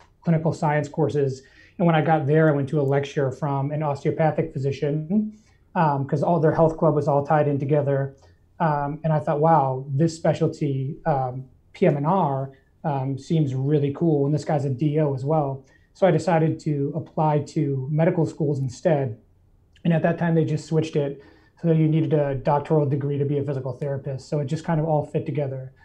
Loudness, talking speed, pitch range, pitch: -23 LUFS, 195 wpm, 140-160 Hz, 150 Hz